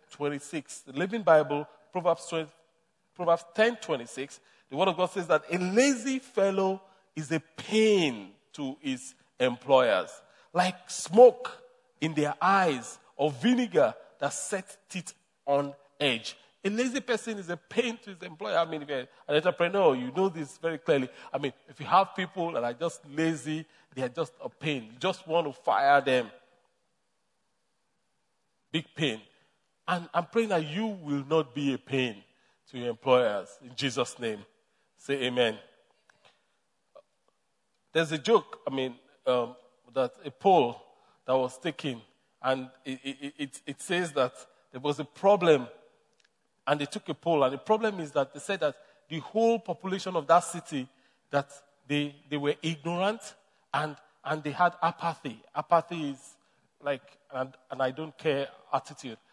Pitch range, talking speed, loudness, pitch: 140-185 Hz, 160 wpm, -29 LUFS, 155 Hz